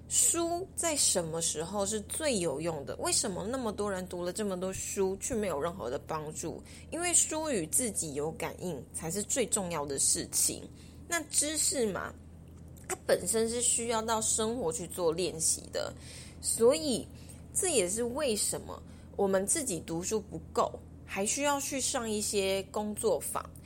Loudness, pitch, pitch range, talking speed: -31 LUFS, 220 Hz, 195-300 Hz, 235 characters per minute